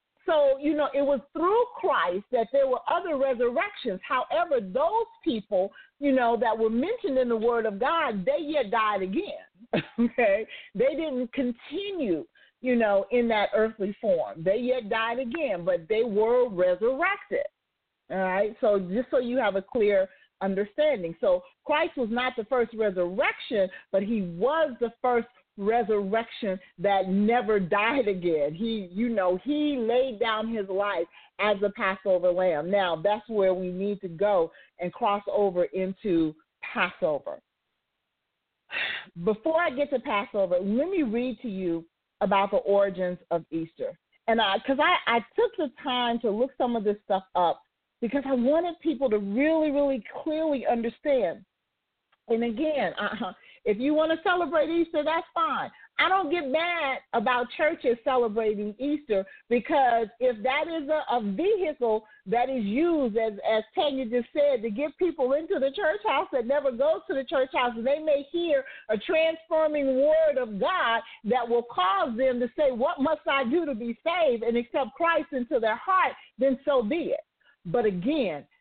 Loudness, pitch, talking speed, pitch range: -26 LUFS, 245 Hz, 165 wpm, 210-295 Hz